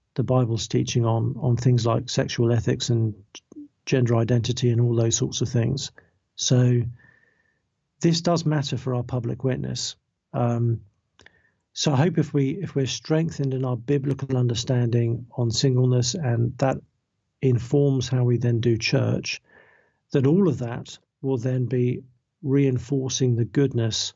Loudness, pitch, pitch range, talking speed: -23 LUFS, 125 Hz, 120-135 Hz, 145 wpm